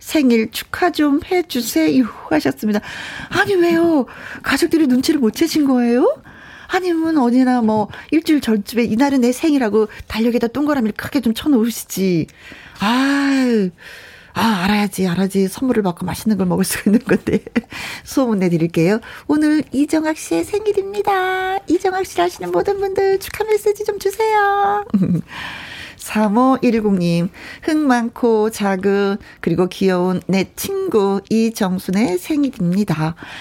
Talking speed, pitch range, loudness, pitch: 295 characters per minute, 205-320 Hz, -17 LUFS, 245 Hz